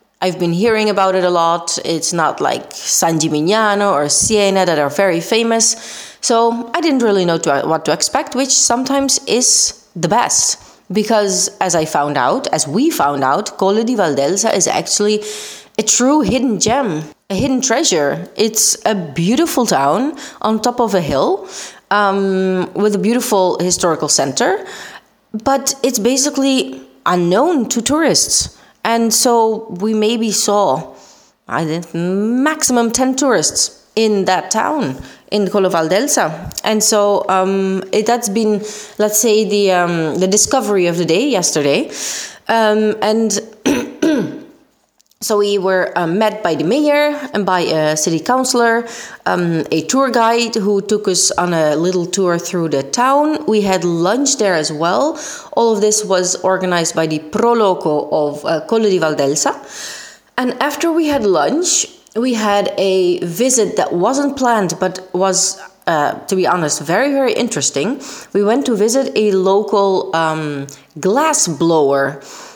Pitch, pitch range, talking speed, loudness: 205 Hz, 175-235 Hz, 150 wpm, -15 LUFS